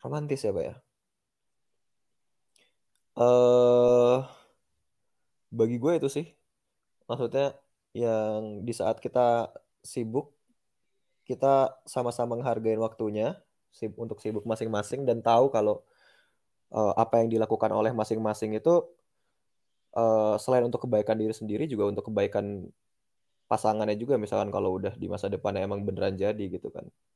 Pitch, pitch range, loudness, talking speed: 115 Hz, 110-125 Hz, -27 LUFS, 120 wpm